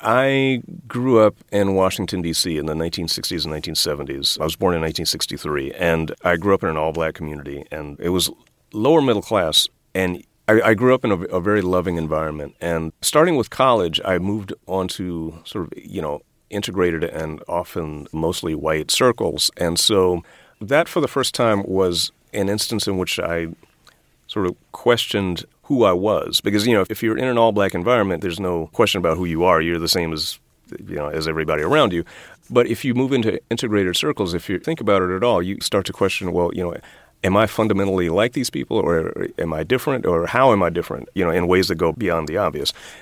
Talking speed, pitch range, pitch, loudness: 210 wpm, 80-105 Hz, 90 Hz, -20 LUFS